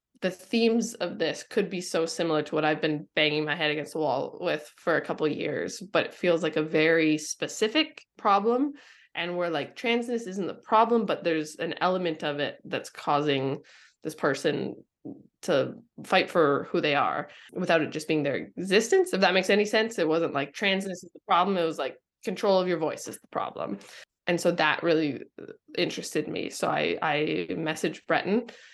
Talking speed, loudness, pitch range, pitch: 195 wpm, -27 LUFS, 155-200 Hz, 170 Hz